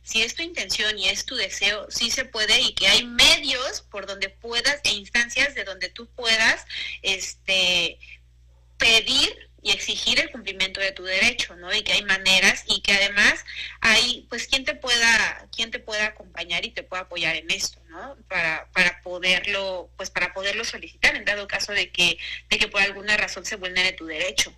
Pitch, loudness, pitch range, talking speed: 200 Hz, -21 LUFS, 185-230 Hz, 190 wpm